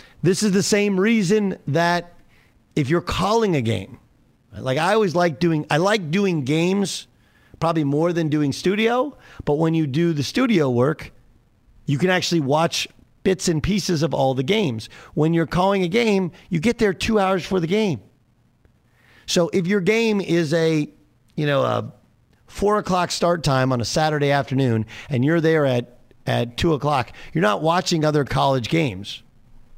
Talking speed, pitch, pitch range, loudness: 175 wpm, 160 Hz, 135-190 Hz, -20 LUFS